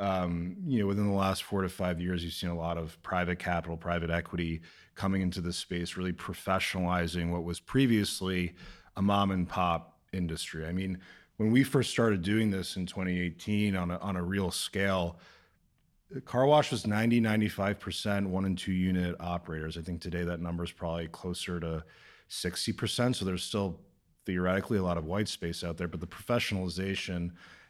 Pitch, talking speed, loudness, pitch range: 90 Hz, 185 wpm, -32 LUFS, 85-100 Hz